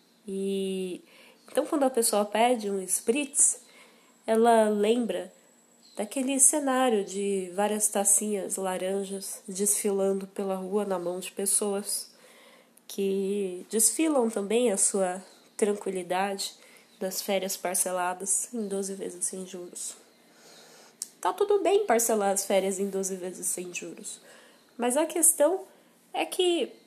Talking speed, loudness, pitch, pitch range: 115 wpm, -27 LUFS, 205 Hz, 195-240 Hz